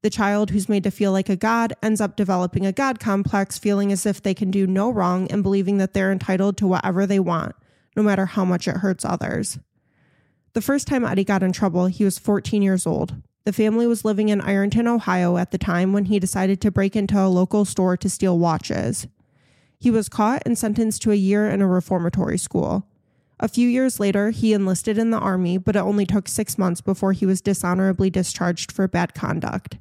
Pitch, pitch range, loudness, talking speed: 195 Hz, 185-210 Hz, -21 LUFS, 215 wpm